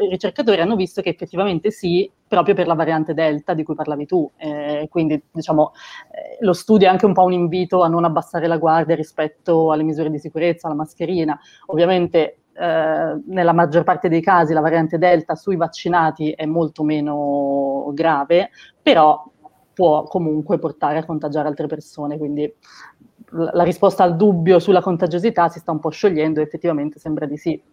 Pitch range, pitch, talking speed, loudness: 155-180 Hz, 165 Hz, 175 wpm, -18 LUFS